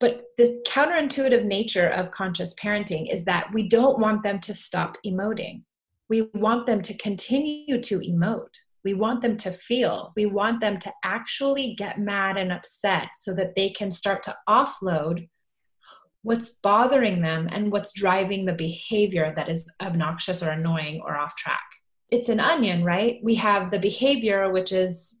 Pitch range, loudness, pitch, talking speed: 185-230 Hz, -24 LUFS, 205 Hz, 165 wpm